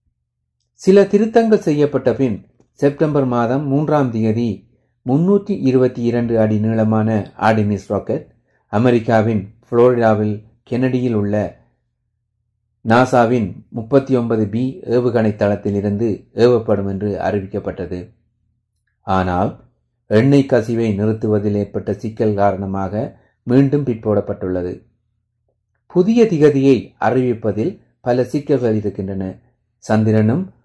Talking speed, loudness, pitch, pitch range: 90 wpm, -17 LUFS, 110 Hz, 105-125 Hz